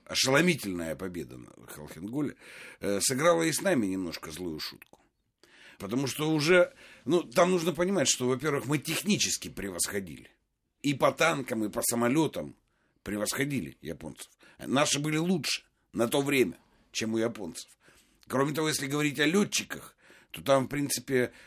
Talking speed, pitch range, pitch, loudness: 140 wpm, 120-160 Hz, 140 Hz, -28 LUFS